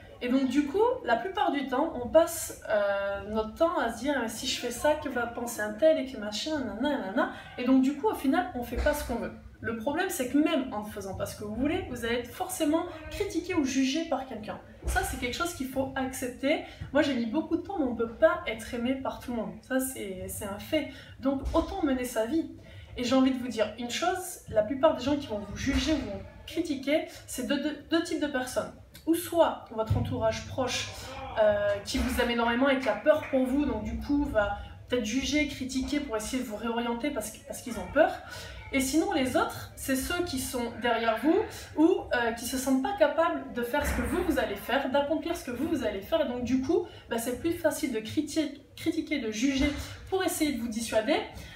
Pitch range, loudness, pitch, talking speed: 245-315 Hz, -29 LUFS, 275 Hz, 245 wpm